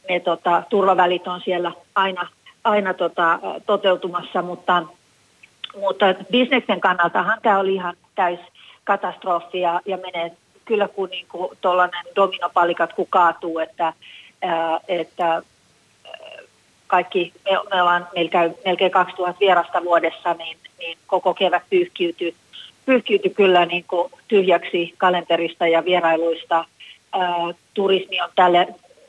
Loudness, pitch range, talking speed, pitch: -20 LUFS, 170-190 Hz, 115 wpm, 180 Hz